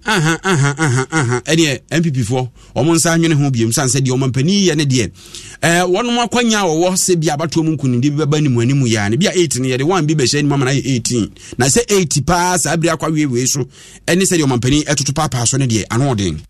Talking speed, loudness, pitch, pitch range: 200 wpm, -15 LUFS, 150 Hz, 130-170 Hz